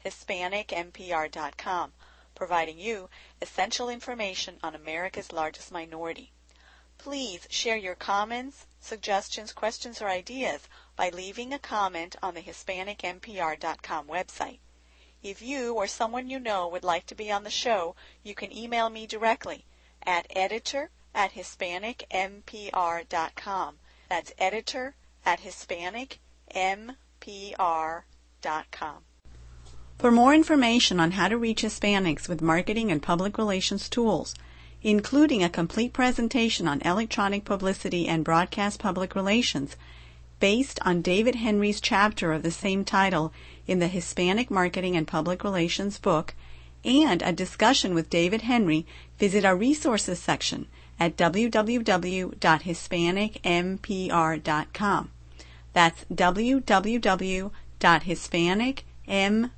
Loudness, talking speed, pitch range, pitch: -26 LUFS, 110 wpm, 170-220 Hz, 190 Hz